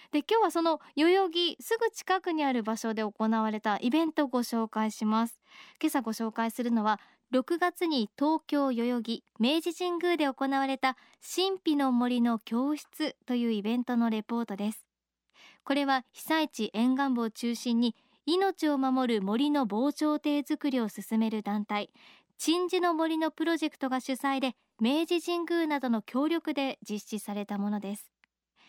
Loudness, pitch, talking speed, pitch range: -30 LUFS, 265 Hz, 305 characters per minute, 225-315 Hz